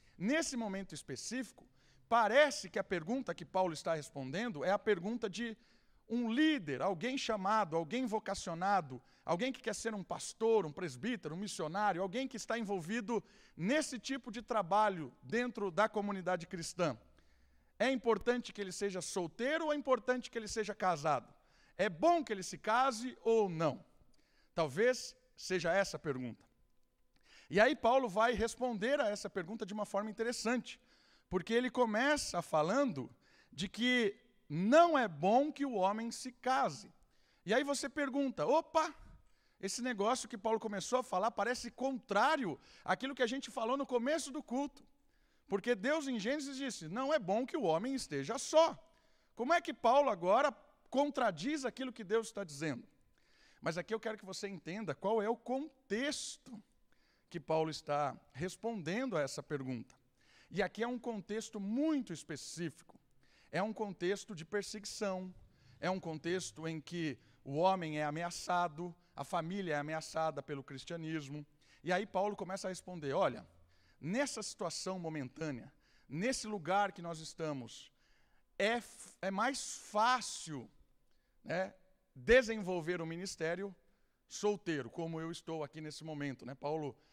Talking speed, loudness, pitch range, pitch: 150 wpm, -37 LUFS, 165-245 Hz, 205 Hz